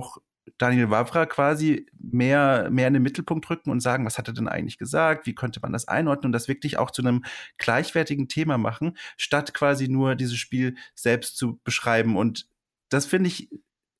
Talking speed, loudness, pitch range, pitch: 185 wpm, -24 LUFS, 120-150 Hz, 130 Hz